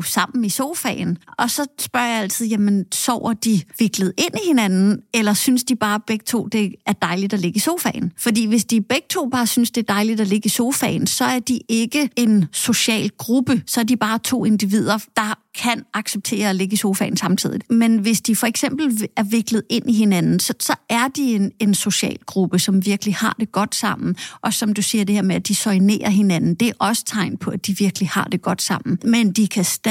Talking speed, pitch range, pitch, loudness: 230 wpm, 200-235 Hz, 220 Hz, -19 LUFS